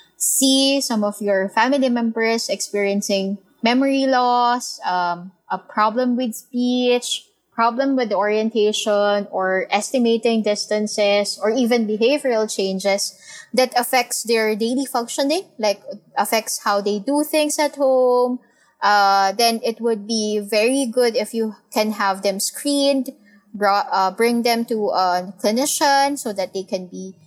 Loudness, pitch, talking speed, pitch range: -19 LUFS, 225 Hz, 135 wpm, 205-250 Hz